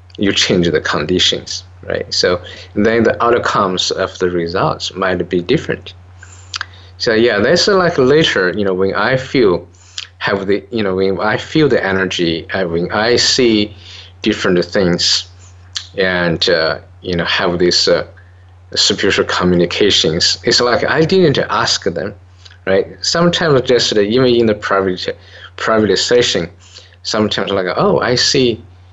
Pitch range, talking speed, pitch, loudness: 90-105 Hz, 145 wpm, 95 Hz, -14 LUFS